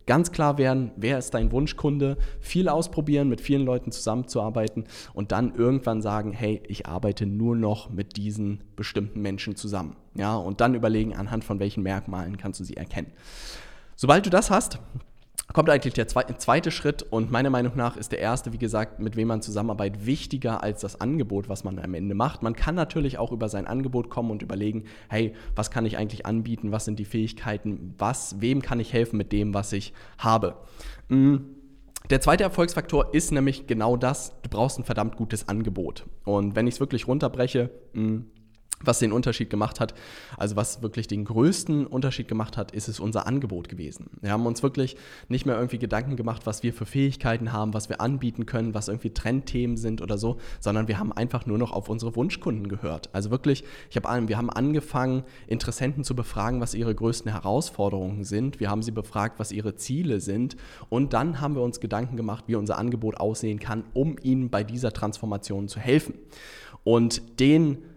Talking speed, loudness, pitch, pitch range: 190 wpm, -27 LUFS, 115 Hz, 105-130 Hz